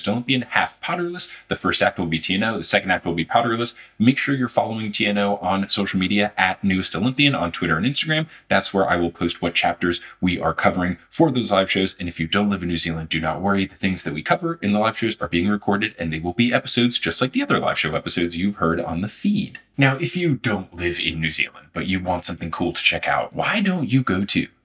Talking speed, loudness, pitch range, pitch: 255 wpm, -21 LUFS, 85-120 Hz, 100 Hz